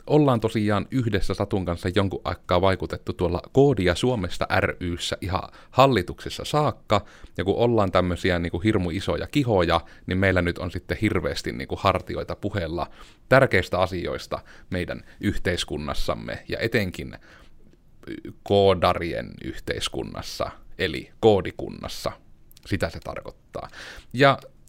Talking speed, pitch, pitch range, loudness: 115 wpm, 95 Hz, 90-105 Hz, -24 LUFS